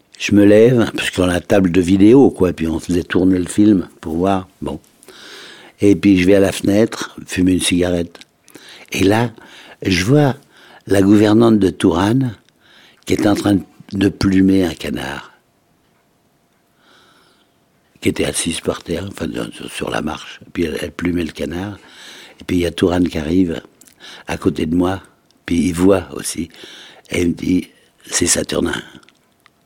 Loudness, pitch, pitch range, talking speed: -16 LUFS, 95 Hz, 90-100 Hz, 170 wpm